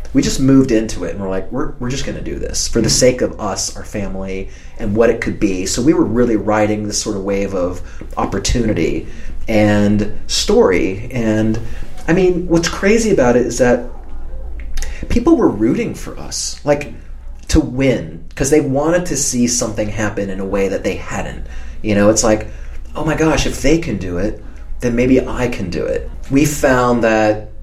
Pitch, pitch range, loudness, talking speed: 105 Hz, 95-130 Hz, -16 LUFS, 200 wpm